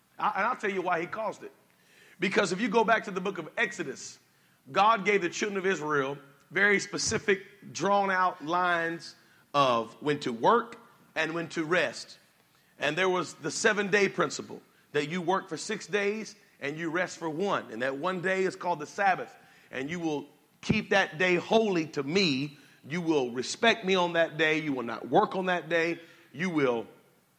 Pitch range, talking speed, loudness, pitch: 155-200 Hz, 190 wpm, -28 LUFS, 180 Hz